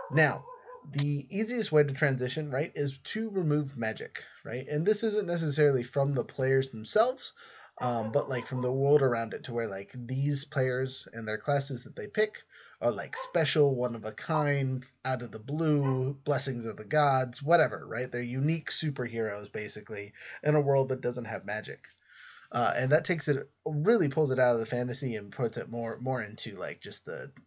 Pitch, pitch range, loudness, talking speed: 135 Hz, 125-150 Hz, -30 LUFS, 190 wpm